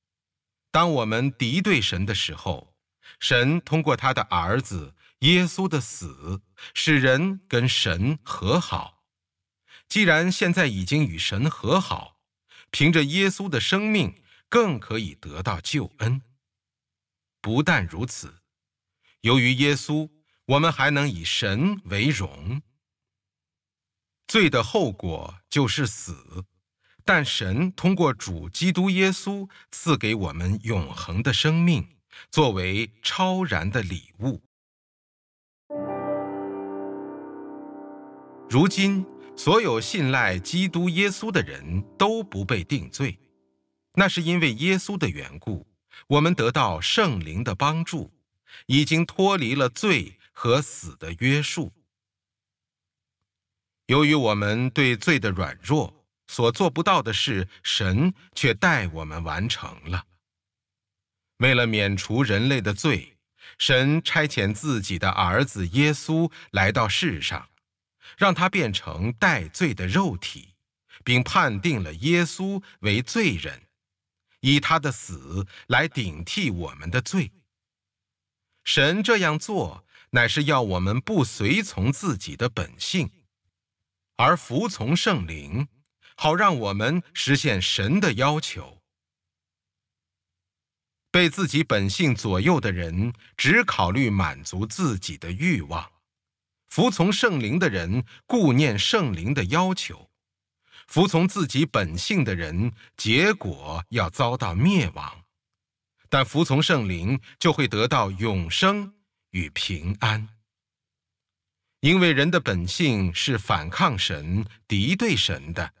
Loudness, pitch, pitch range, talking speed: -23 LUFS, 115 Hz, 95-155 Hz, 170 characters per minute